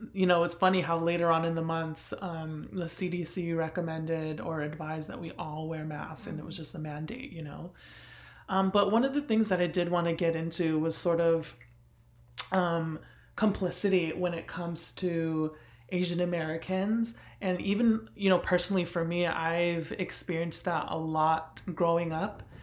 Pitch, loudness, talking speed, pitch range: 170 Hz, -31 LUFS, 180 wpm, 160-180 Hz